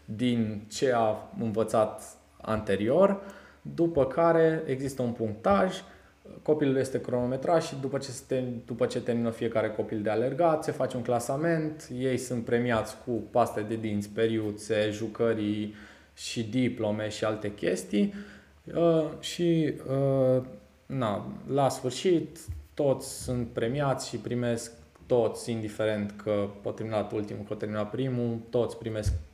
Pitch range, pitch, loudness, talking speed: 110-135 Hz, 120 Hz, -29 LUFS, 120 wpm